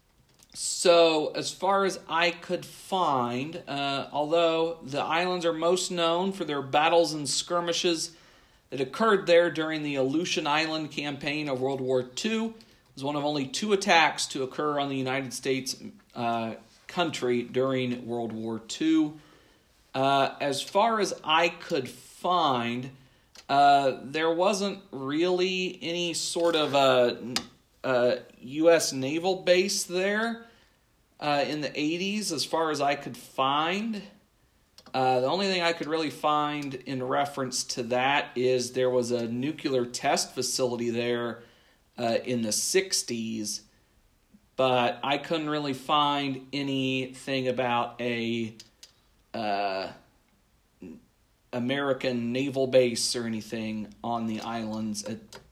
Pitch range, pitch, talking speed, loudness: 125-170 Hz, 140 Hz, 130 wpm, -27 LUFS